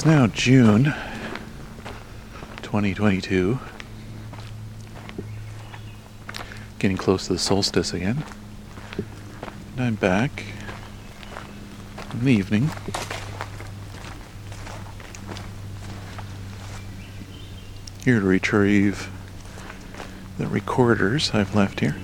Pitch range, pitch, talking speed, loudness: 100-110 Hz, 100 Hz, 65 wpm, -22 LUFS